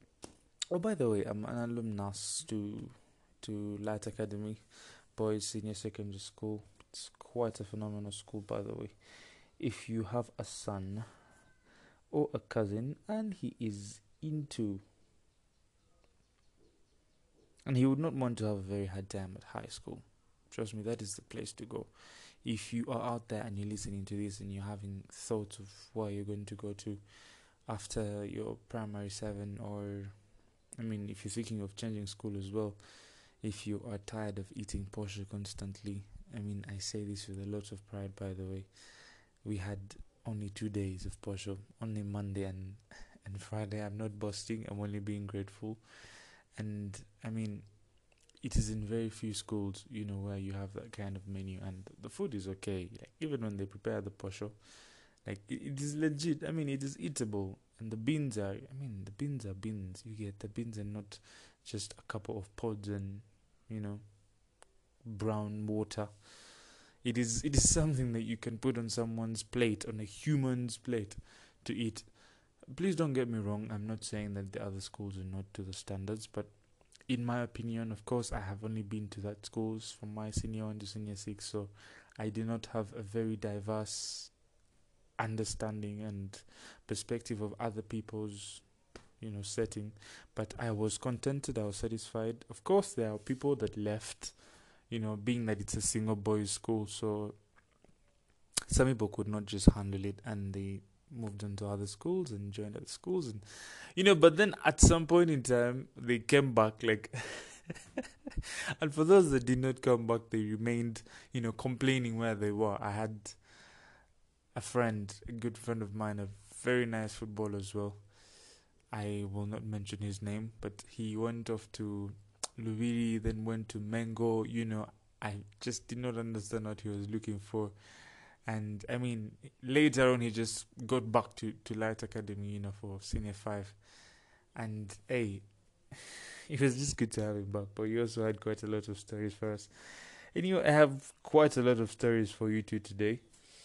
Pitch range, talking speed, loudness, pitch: 100-115 Hz, 180 wpm, -37 LUFS, 110 Hz